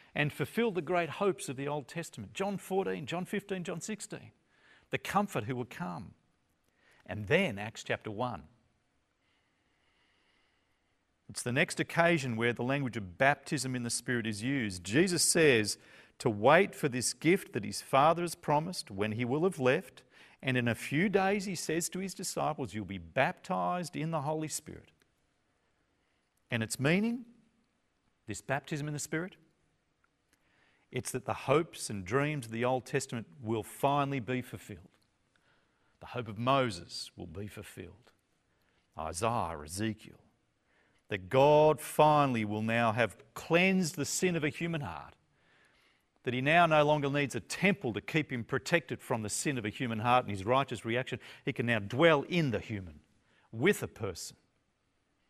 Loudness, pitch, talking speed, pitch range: -32 LUFS, 135 Hz, 165 wpm, 115-165 Hz